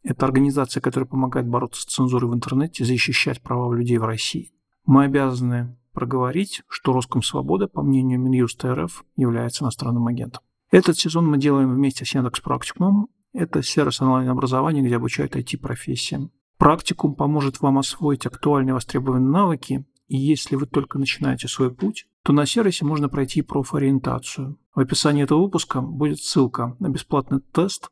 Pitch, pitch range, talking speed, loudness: 135 Hz, 125-150 Hz, 155 wpm, -21 LUFS